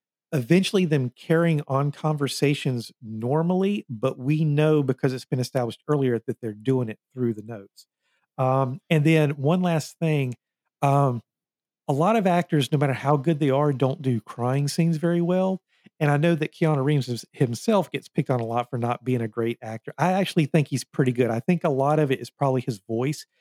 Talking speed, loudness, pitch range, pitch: 200 wpm, -24 LUFS, 125-160 Hz, 140 Hz